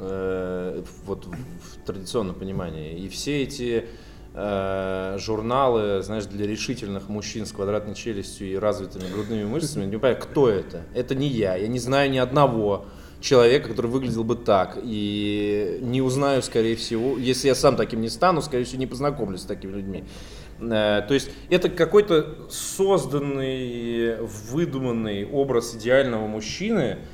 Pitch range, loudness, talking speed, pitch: 100-130 Hz, -24 LUFS, 145 wpm, 115 Hz